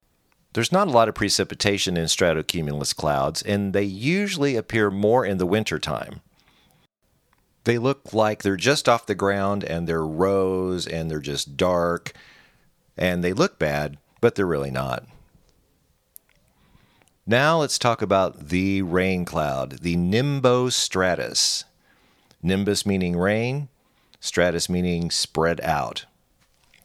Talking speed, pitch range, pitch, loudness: 125 wpm, 85-110 Hz, 95 Hz, -23 LUFS